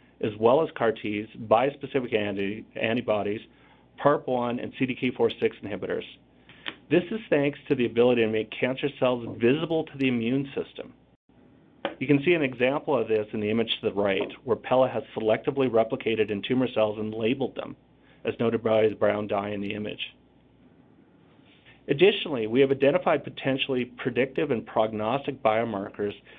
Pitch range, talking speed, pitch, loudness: 110-135 Hz, 155 wpm, 120 Hz, -26 LUFS